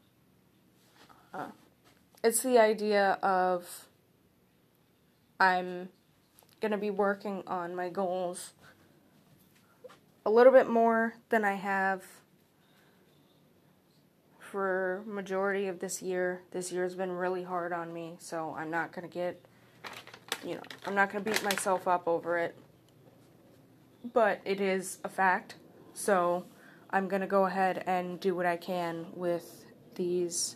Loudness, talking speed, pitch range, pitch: -30 LUFS, 130 wpm, 175-195 Hz, 185 Hz